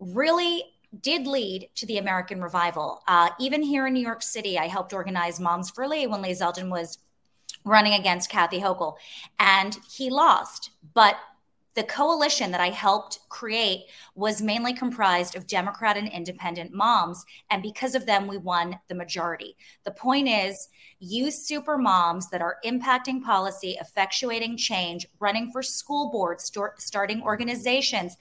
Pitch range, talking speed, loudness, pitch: 180-245 Hz, 155 wpm, -25 LUFS, 200 Hz